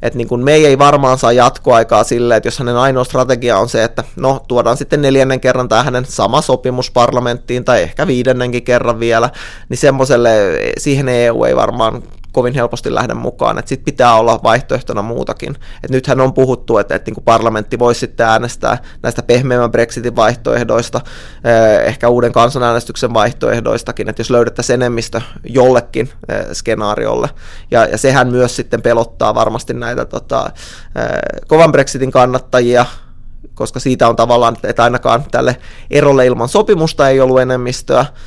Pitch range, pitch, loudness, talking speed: 120-130 Hz, 125 Hz, -12 LUFS, 150 wpm